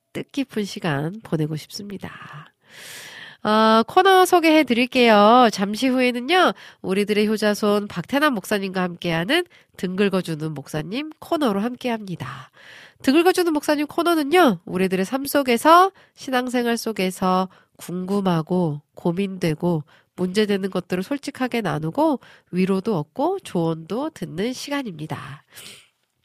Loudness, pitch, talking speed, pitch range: -21 LUFS, 210 Hz, 290 characters per minute, 180-270 Hz